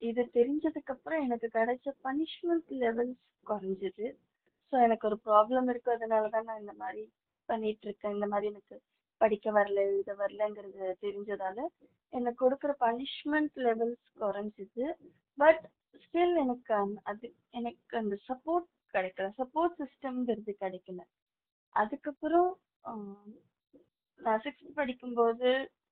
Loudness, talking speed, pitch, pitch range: -33 LUFS, 105 wpm, 235 Hz, 205-275 Hz